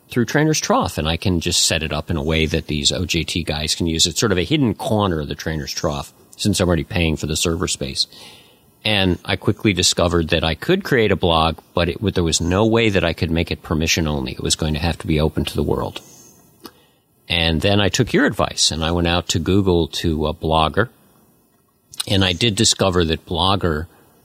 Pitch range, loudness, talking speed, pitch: 80-95 Hz, -18 LUFS, 230 wpm, 85 Hz